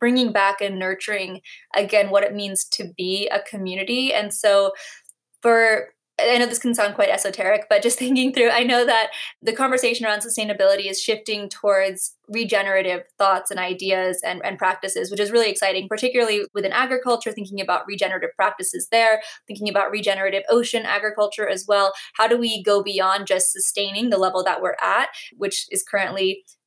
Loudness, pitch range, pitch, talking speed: -20 LUFS, 195-235 Hz, 205 Hz, 175 wpm